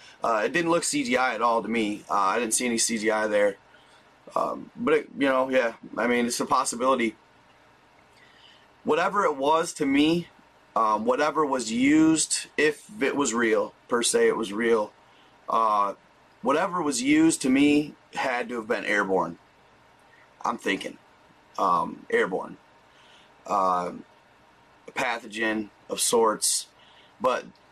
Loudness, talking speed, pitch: -25 LUFS, 145 wpm, 140 Hz